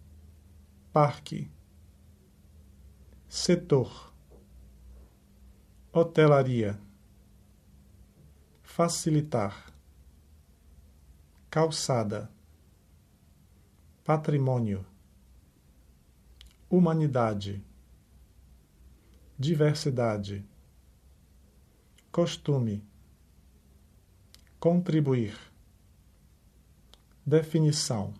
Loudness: -28 LUFS